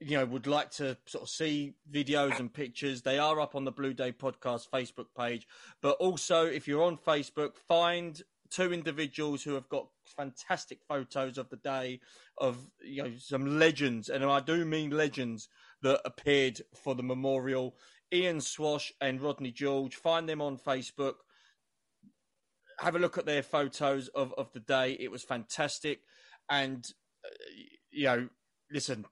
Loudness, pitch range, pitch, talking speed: -33 LUFS, 130-155 Hz, 140 Hz, 165 wpm